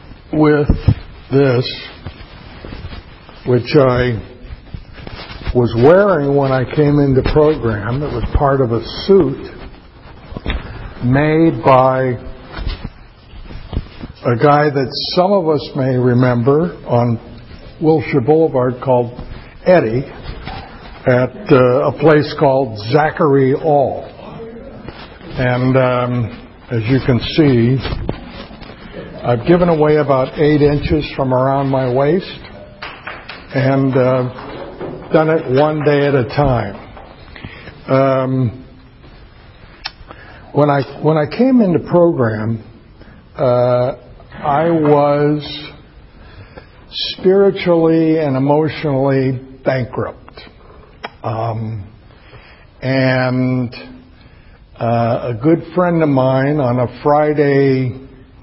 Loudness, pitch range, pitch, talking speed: -14 LUFS, 120-150 Hz, 130 Hz, 90 wpm